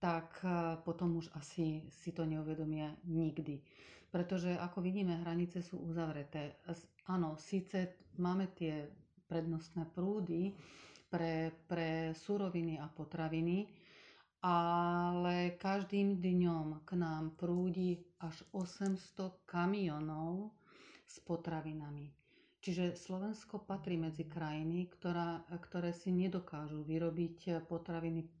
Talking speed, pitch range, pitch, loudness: 100 wpm, 160-180 Hz, 170 Hz, -40 LUFS